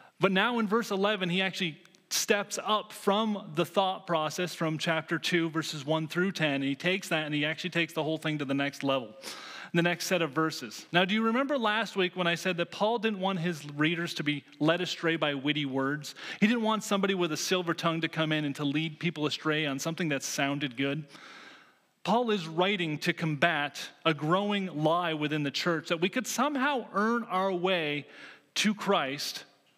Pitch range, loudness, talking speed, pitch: 155-195 Hz, -29 LUFS, 205 wpm, 170 Hz